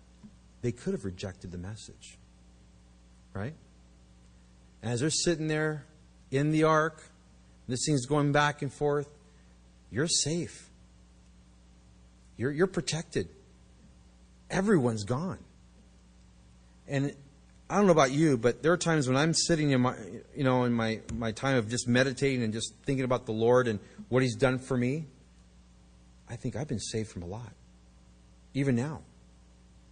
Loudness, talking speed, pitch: -29 LUFS, 145 wpm, 115 Hz